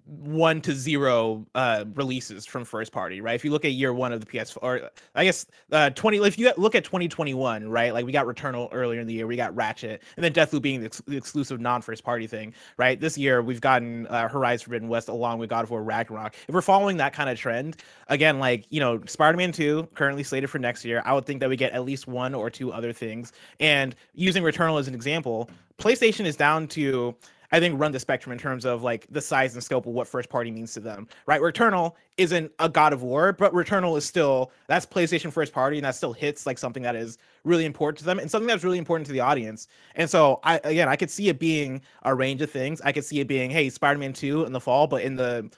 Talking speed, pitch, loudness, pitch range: 250 wpm, 135 Hz, -25 LUFS, 120-155 Hz